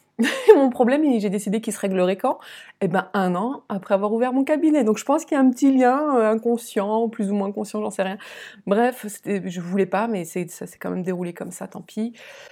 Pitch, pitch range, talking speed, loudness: 215 Hz, 195-255 Hz, 235 wpm, -21 LUFS